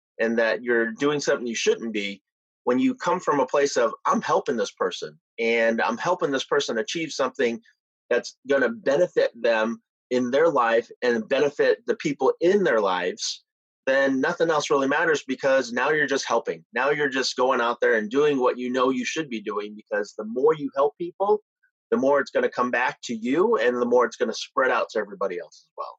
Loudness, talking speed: -24 LUFS, 210 wpm